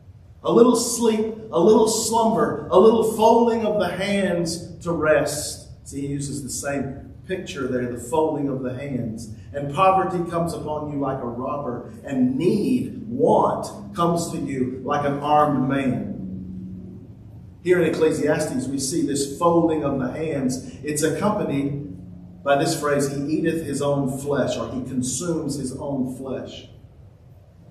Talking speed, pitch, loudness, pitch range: 150 wpm, 145 Hz, -22 LUFS, 130-170 Hz